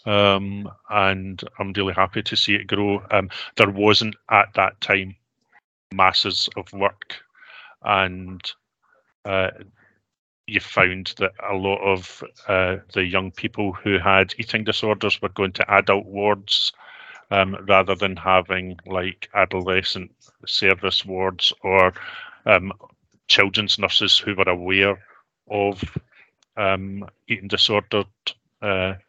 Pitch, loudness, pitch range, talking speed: 100 Hz, -20 LUFS, 95-105 Hz, 120 wpm